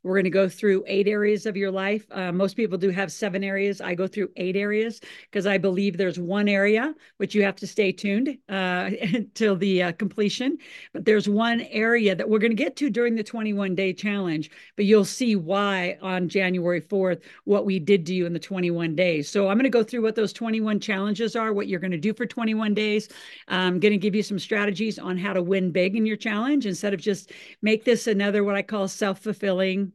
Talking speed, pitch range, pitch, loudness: 230 wpm, 190-215 Hz, 200 Hz, -24 LUFS